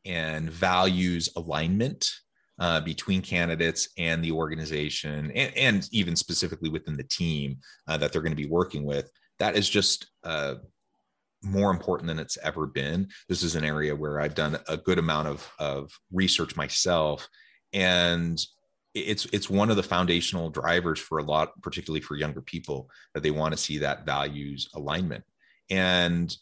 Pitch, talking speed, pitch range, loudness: 80 Hz, 165 wpm, 75-90 Hz, -27 LUFS